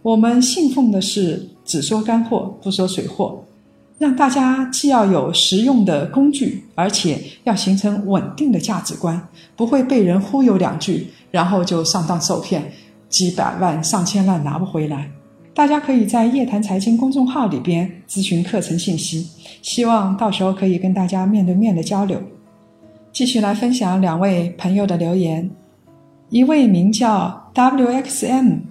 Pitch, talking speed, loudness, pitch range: 195 Hz, 245 characters per minute, -17 LUFS, 180-235 Hz